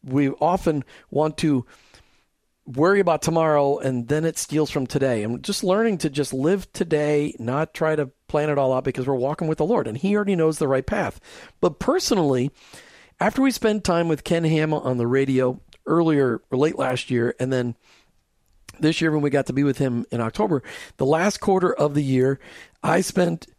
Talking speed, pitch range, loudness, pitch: 200 wpm, 130-165 Hz, -22 LUFS, 150 Hz